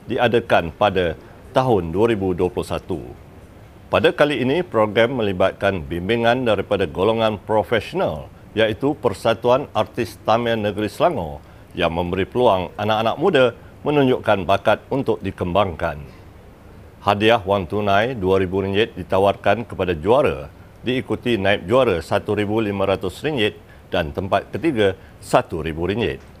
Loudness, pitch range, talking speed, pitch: -20 LUFS, 95-110 Hz, 100 wpm, 100 Hz